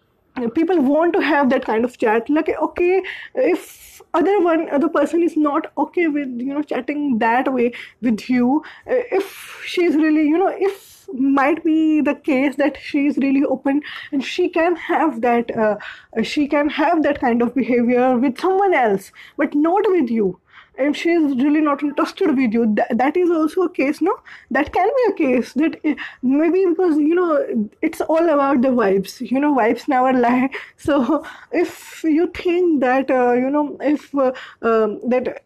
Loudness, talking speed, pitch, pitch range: -18 LUFS, 180 wpm, 295 Hz, 255-335 Hz